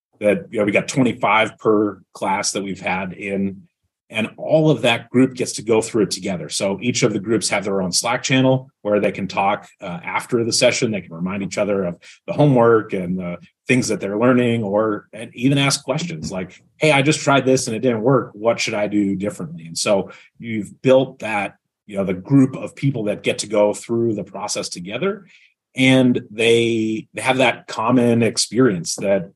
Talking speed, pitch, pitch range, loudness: 205 wpm, 115 Hz, 100-130 Hz, -19 LUFS